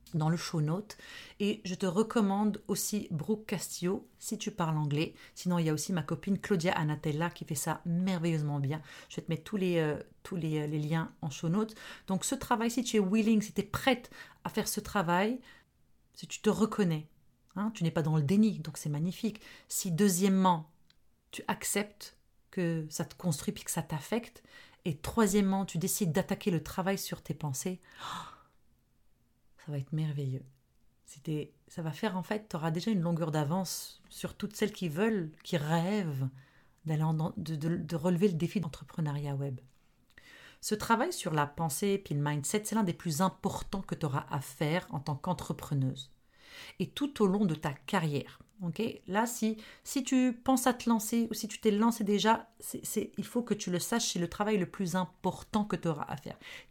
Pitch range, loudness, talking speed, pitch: 155-210 Hz, -33 LUFS, 200 wpm, 180 Hz